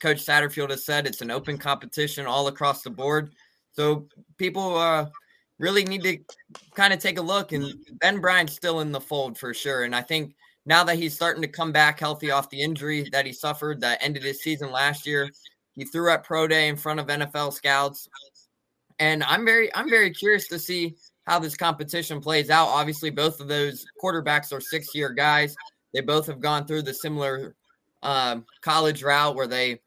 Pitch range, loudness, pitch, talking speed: 140-165 Hz, -24 LUFS, 150 Hz, 195 wpm